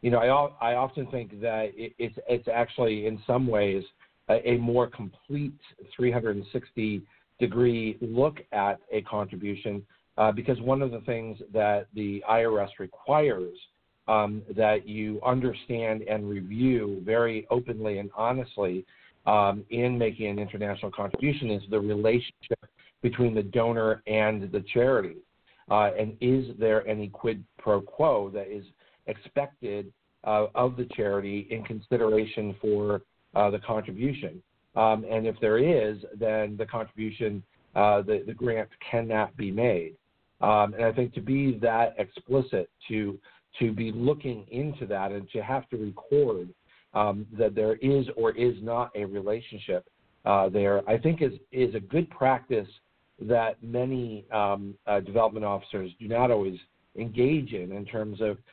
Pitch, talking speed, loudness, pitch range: 110 Hz, 150 wpm, -28 LUFS, 105-125 Hz